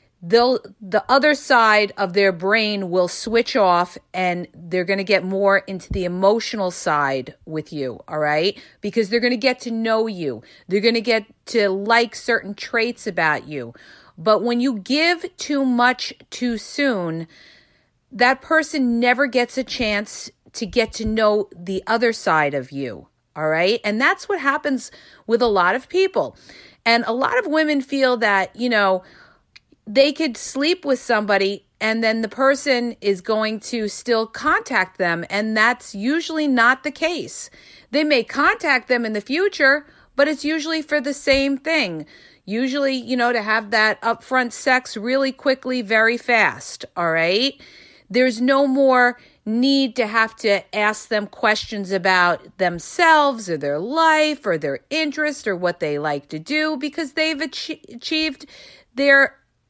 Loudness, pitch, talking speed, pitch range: -19 LUFS, 230 Hz, 160 wpm, 200-275 Hz